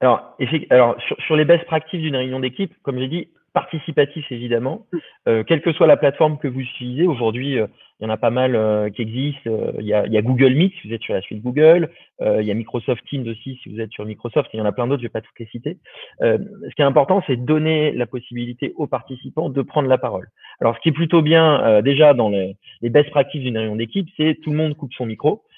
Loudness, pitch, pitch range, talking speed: -19 LUFS, 130 Hz, 120-155 Hz, 265 wpm